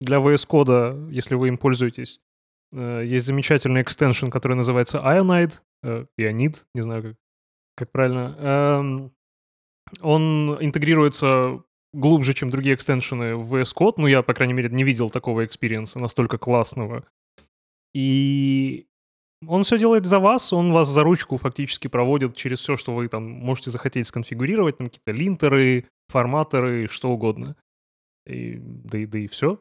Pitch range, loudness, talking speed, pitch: 115-145 Hz, -21 LUFS, 145 wpm, 130 Hz